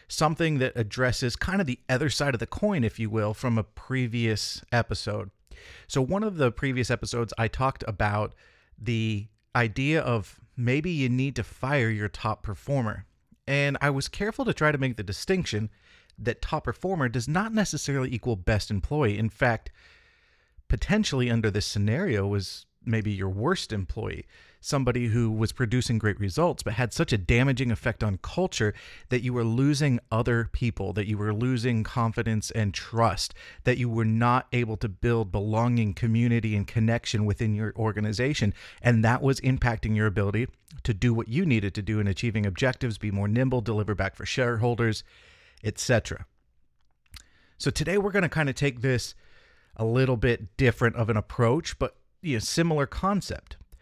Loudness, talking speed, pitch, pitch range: -27 LUFS, 175 wpm, 115 Hz, 105-130 Hz